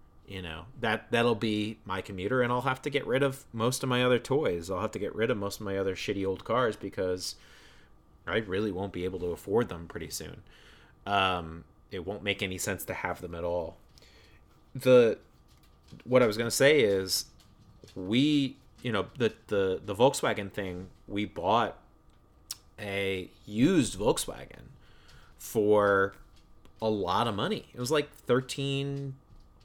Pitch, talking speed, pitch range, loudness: 100 Hz, 170 wpm, 90-120 Hz, -29 LUFS